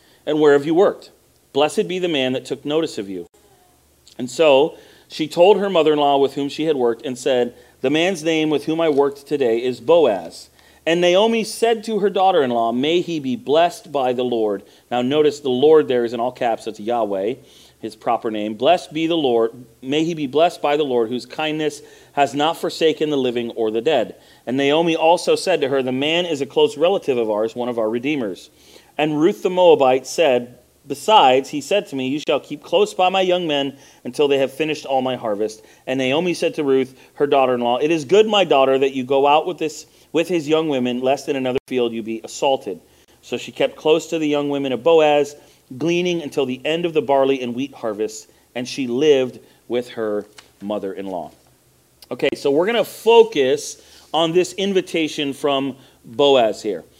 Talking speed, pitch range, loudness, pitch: 205 wpm, 125-165 Hz, -19 LUFS, 145 Hz